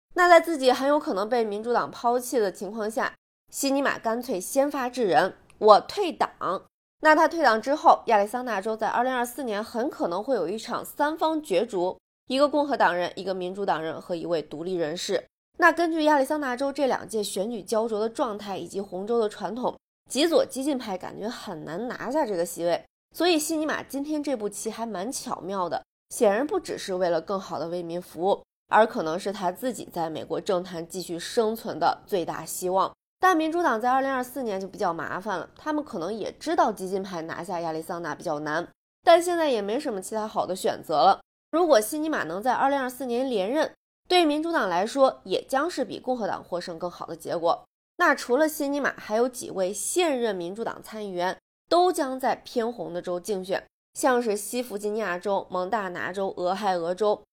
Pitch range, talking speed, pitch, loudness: 190-285 Hz, 305 characters per minute, 230 Hz, -26 LUFS